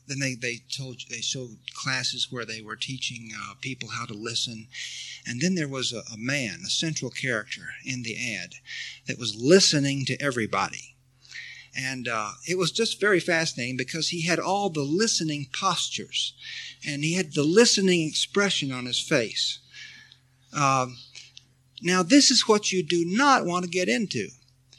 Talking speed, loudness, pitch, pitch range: 165 wpm, -25 LUFS, 130 Hz, 125-170 Hz